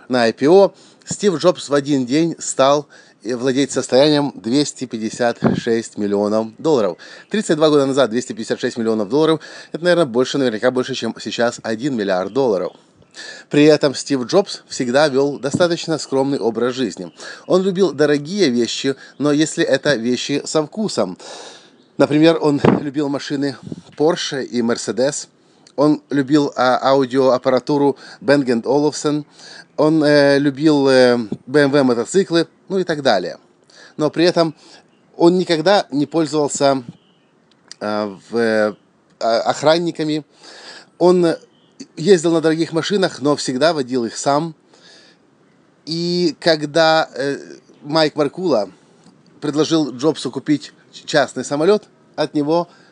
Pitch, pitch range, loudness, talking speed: 145 Hz, 130-160 Hz, -17 LUFS, 120 wpm